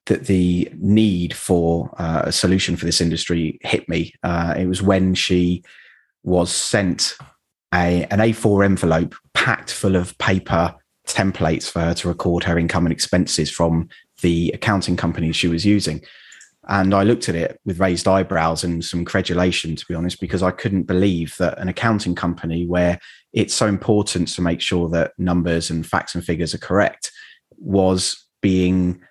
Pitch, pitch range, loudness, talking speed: 90 Hz, 85-95 Hz, -19 LUFS, 170 wpm